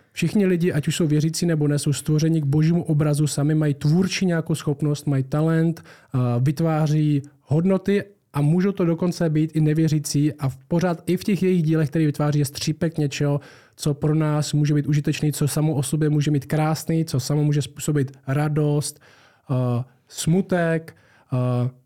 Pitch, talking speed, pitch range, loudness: 150 Hz, 160 wpm, 145-165 Hz, -22 LUFS